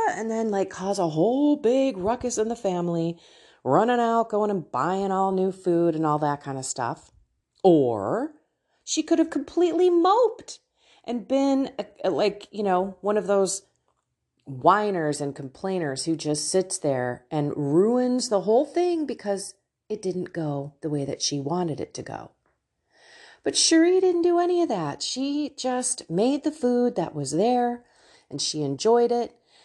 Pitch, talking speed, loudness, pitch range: 200 Hz, 170 wpm, -24 LUFS, 165-250 Hz